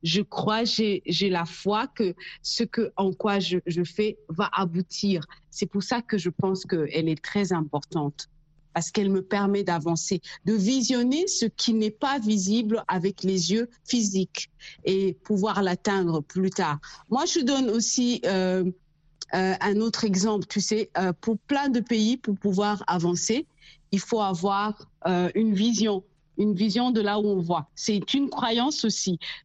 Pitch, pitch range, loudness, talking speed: 200 Hz, 180-220 Hz, -26 LUFS, 170 wpm